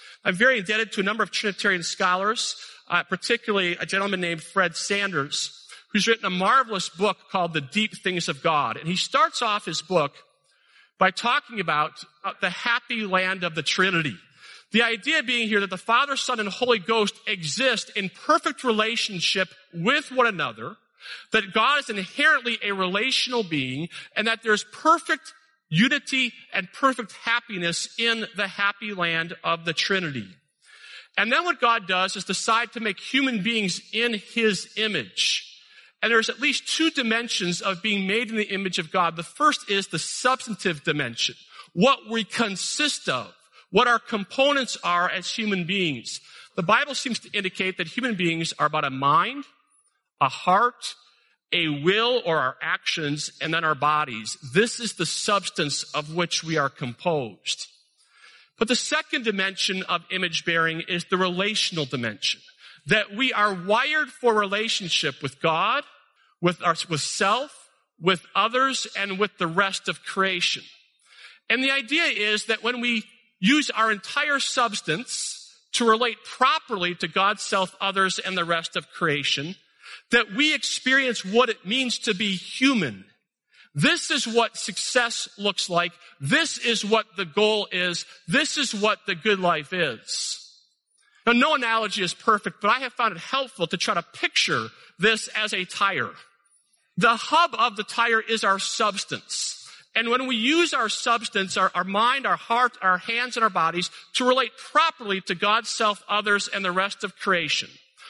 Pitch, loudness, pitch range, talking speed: 210 Hz, -23 LUFS, 180-240 Hz, 165 wpm